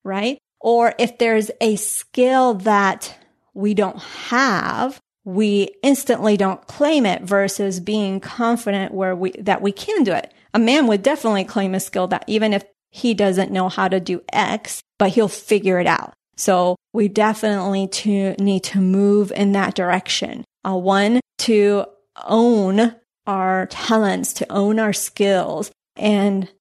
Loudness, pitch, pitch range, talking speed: -19 LUFS, 200 Hz, 195-220 Hz, 155 wpm